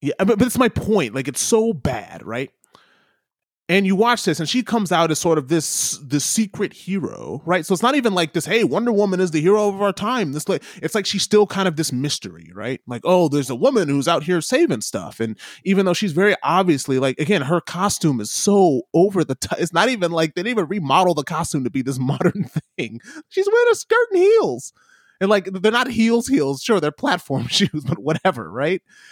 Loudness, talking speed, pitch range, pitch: -19 LUFS, 230 wpm, 150-210 Hz, 180 Hz